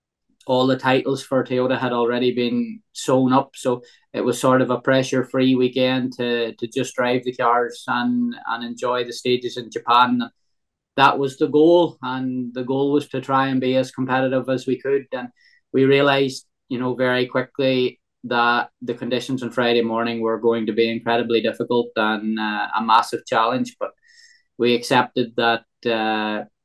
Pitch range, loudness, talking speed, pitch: 120-135 Hz, -20 LUFS, 175 wpm, 125 Hz